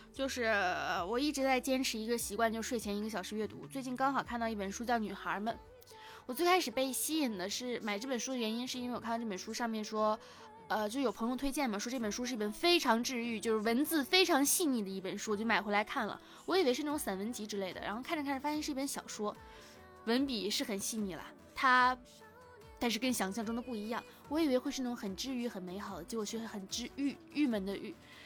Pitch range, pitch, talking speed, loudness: 215-270 Hz, 235 Hz, 355 characters per minute, -35 LUFS